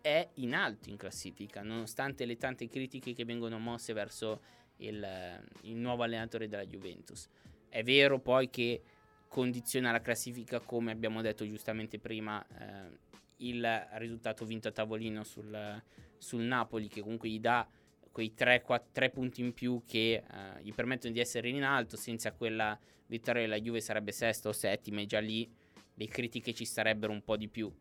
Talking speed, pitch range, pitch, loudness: 165 wpm, 110-120 Hz, 115 Hz, -36 LUFS